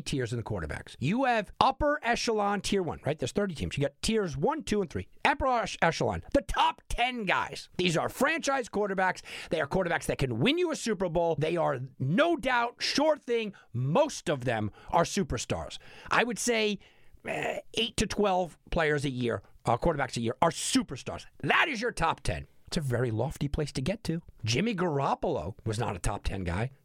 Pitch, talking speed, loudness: 175 Hz, 200 wpm, -29 LUFS